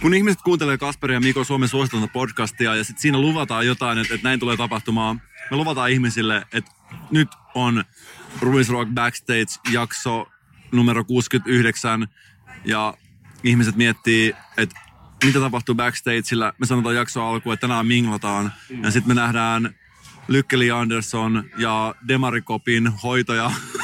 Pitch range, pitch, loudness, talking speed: 115-130 Hz, 120 Hz, -20 LUFS, 135 wpm